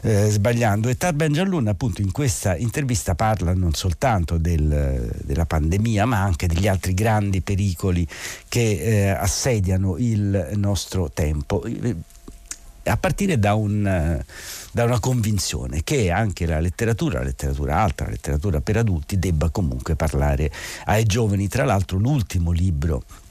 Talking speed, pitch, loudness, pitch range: 140 wpm, 100 Hz, -22 LUFS, 85-110 Hz